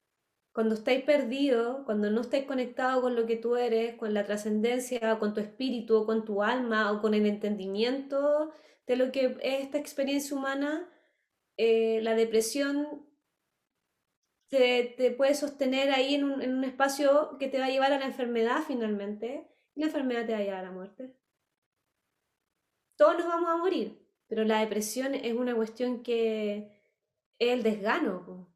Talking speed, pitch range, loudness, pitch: 170 wpm, 220-275 Hz, -29 LUFS, 250 Hz